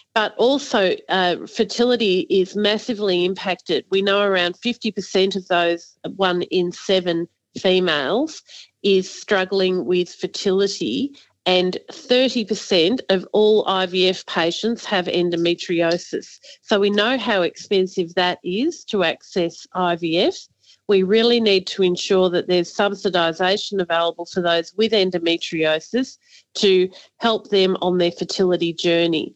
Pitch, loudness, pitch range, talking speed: 185 Hz, -20 LUFS, 175-210 Hz, 120 wpm